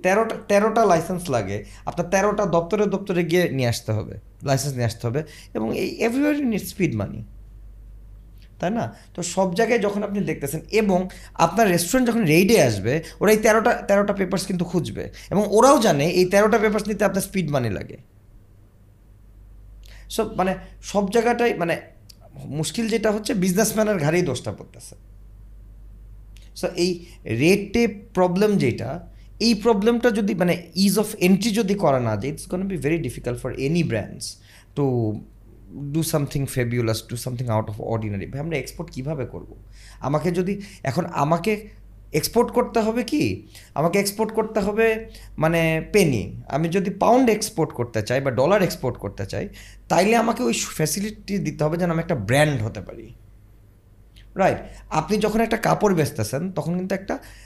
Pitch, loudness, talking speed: 160 Hz, -22 LUFS, 155 wpm